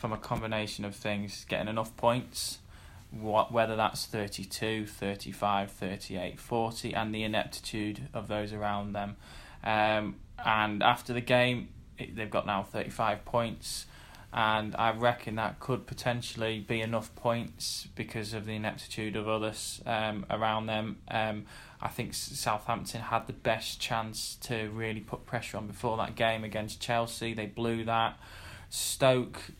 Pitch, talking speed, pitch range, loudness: 110 Hz, 145 wpm, 105-115 Hz, -32 LUFS